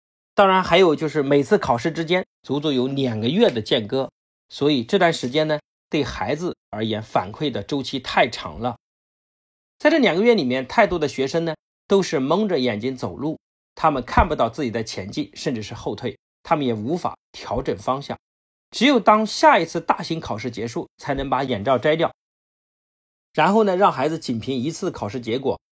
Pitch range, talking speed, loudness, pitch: 130-180 Hz, 275 characters per minute, -21 LUFS, 150 Hz